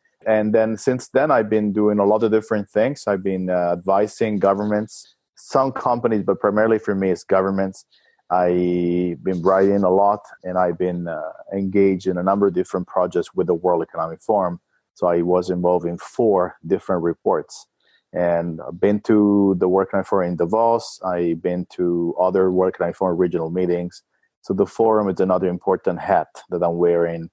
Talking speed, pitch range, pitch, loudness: 180 wpm, 90-105 Hz, 95 Hz, -20 LUFS